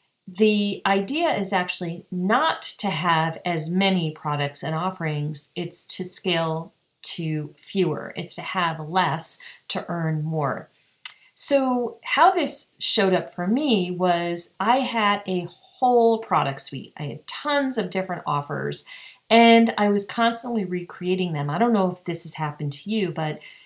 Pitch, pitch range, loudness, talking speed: 180 Hz, 160-205 Hz, -23 LUFS, 150 wpm